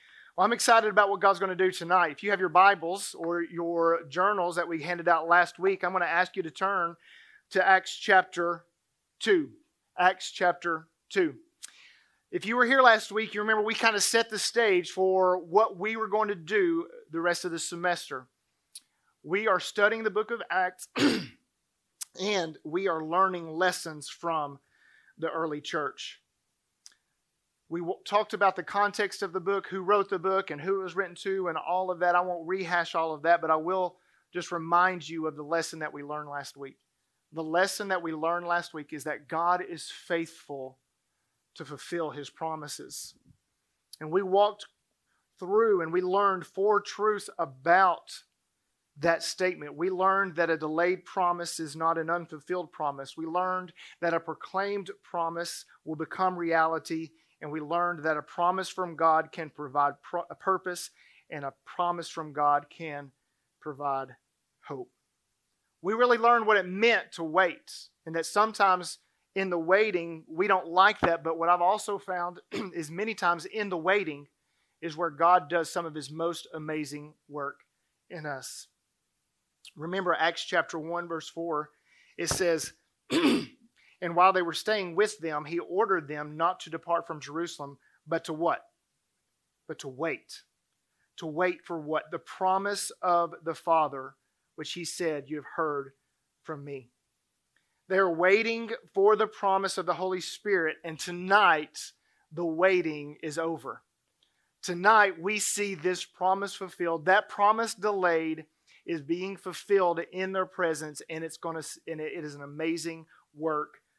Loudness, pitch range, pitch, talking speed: -28 LUFS, 160-195 Hz, 175 Hz, 165 wpm